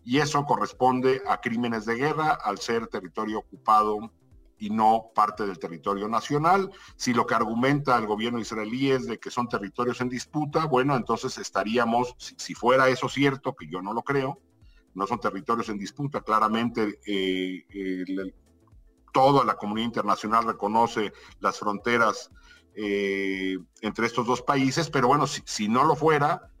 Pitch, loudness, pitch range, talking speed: 115 Hz, -26 LUFS, 105-130 Hz, 160 wpm